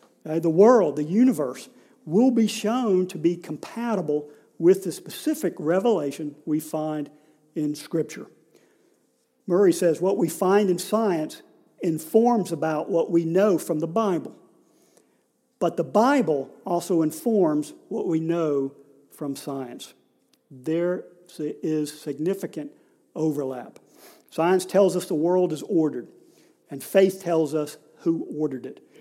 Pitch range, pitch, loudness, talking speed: 155-195 Hz, 170 Hz, -24 LUFS, 130 wpm